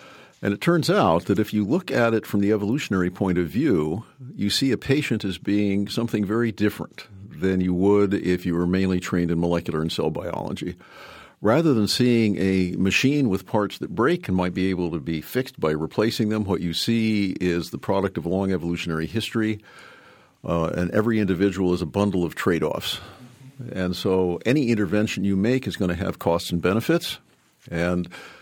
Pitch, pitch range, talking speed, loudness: 100 Hz, 90-110 Hz, 190 wpm, -23 LUFS